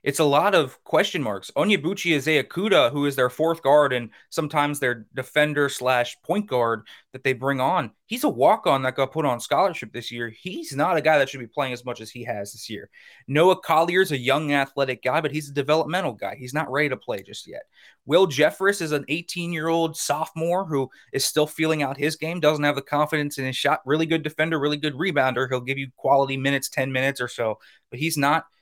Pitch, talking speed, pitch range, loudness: 145 Hz, 230 wpm, 130-160 Hz, -23 LUFS